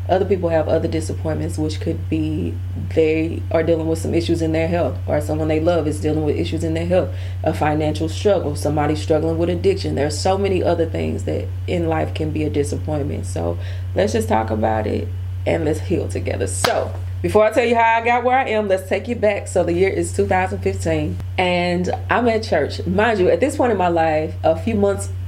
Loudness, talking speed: -19 LUFS, 220 wpm